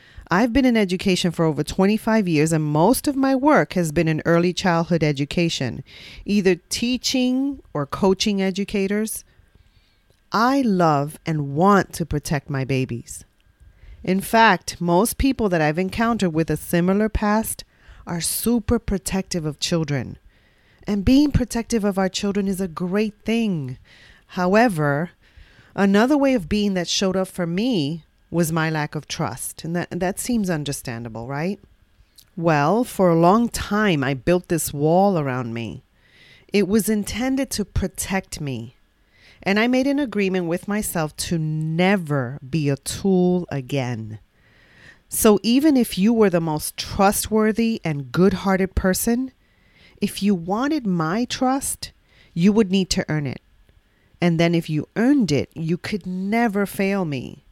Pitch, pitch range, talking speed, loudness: 180 Hz, 150-210 Hz, 150 wpm, -21 LUFS